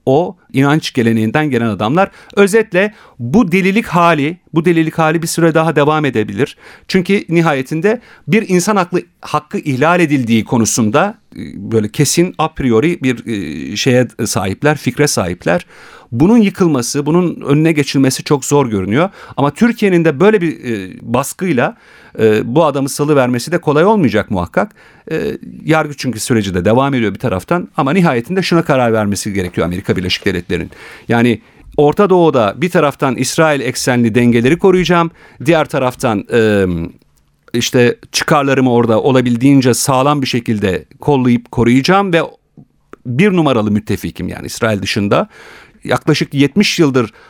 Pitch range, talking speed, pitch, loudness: 115-165 Hz, 135 wpm, 140 Hz, -13 LUFS